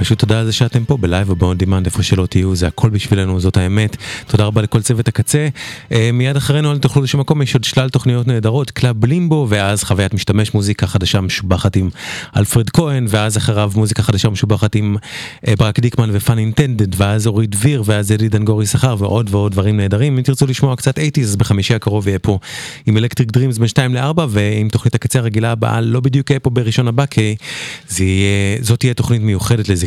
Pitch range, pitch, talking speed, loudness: 105-130 Hz, 115 Hz, 165 wpm, -15 LUFS